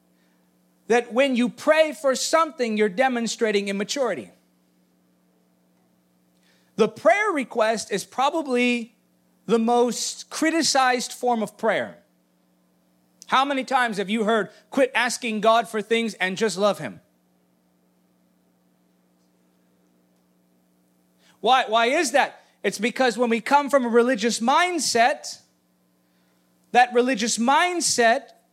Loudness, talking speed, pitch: -22 LUFS, 105 wpm, 215 Hz